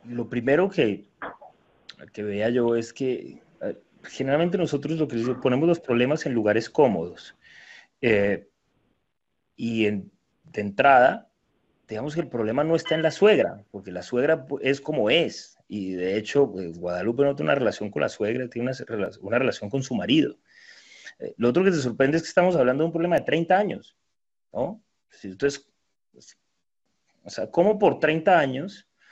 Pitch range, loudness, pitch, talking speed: 110-160 Hz, -24 LUFS, 130 Hz, 170 wpm